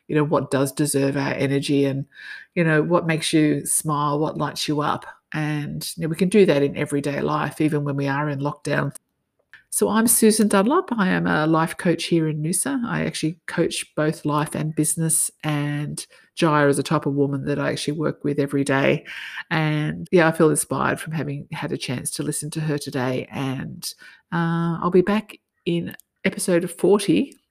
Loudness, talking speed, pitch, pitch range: -22 LUFS, 195 wpm, 155 Hz, 145-170 Hz